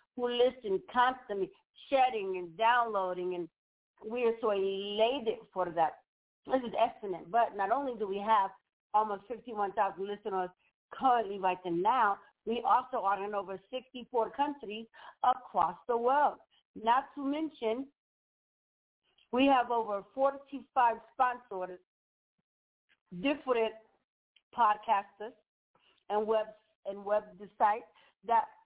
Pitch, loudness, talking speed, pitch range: 225 Hz, -32 LUFS, 115 wpm, 200-250 Hz